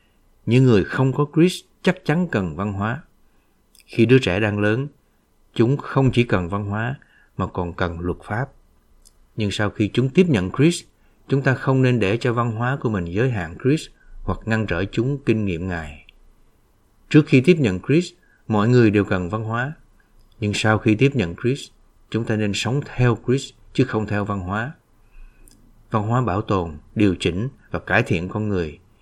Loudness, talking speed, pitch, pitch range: -21 LUFS, 190 wpm, 110 Hz, 100-130 Hz